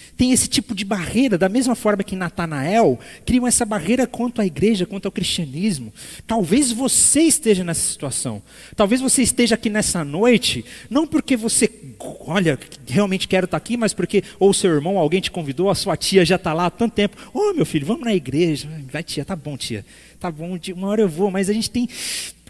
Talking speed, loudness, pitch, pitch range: 210 wpm, -19 LUFS, 195 Hz, 175-230 Hz